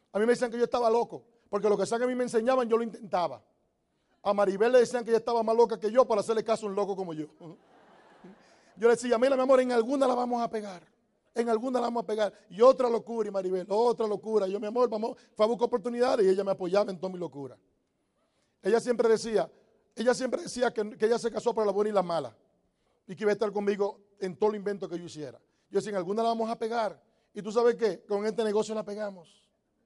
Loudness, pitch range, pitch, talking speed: -28 LUFS, 205-235 Hz, 220 Hz, 255 wpm